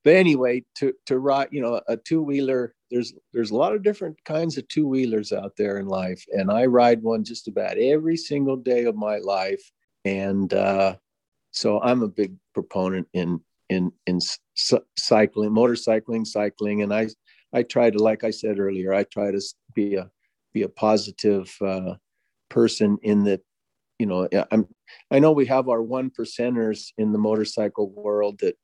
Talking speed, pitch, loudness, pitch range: 180 wpm, 110 Hz, -23 LUFS, 100-125 Hz